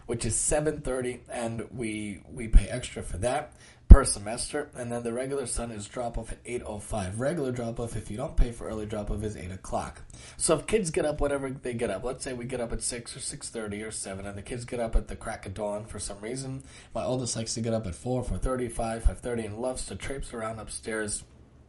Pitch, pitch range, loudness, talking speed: 115 Hz, 105-125 Hz, -30 LUFS, 255 wpm